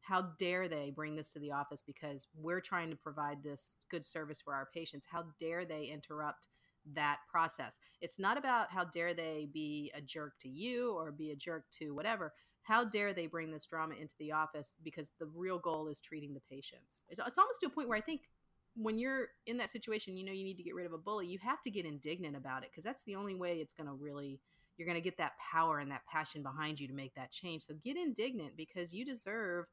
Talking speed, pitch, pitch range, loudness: 240 wpm, 160 Hz, 150-190 Hz, -41 LUFS